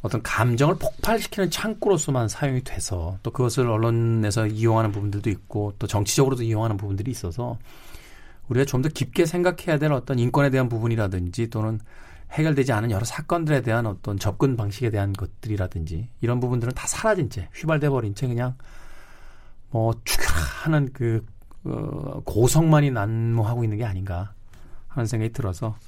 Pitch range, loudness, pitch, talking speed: 105-135 Hz, -24 LUFS, 115 Hz, 370 characters per minute